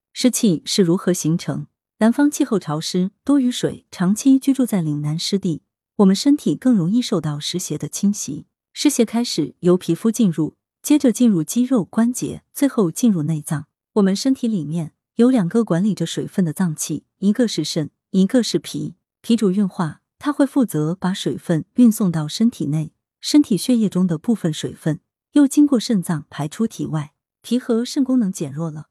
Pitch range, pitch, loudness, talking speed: 160-235 Hz, 190 Hz, -19 LUFS, 270 characters per minute